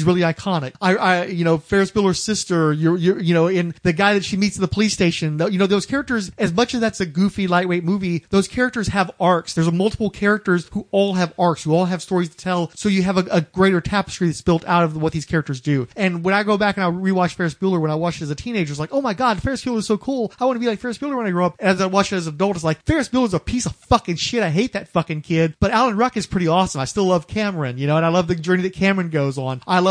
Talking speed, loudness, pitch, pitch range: 305 wpm, -19 LUFS, 185 Hz, 170-205 Hz